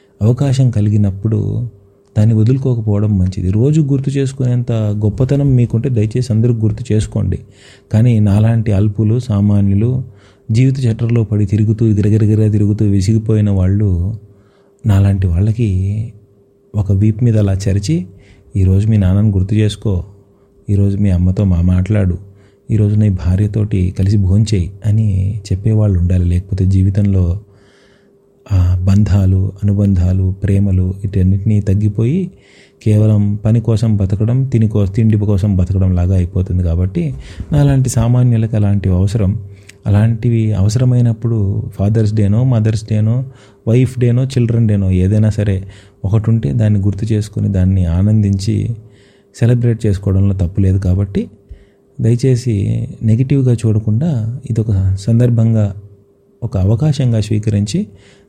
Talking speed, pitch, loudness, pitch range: 110 wpm, 105 Hz, -14 LUFS, 100-115 Hz